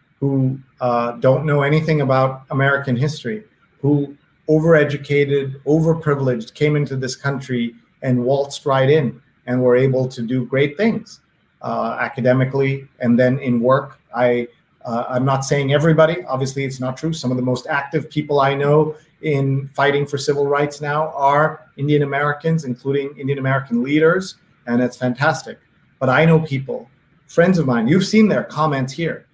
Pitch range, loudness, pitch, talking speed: 130-155 Hz, -18 LUFS, 140 Hz, 160 wpm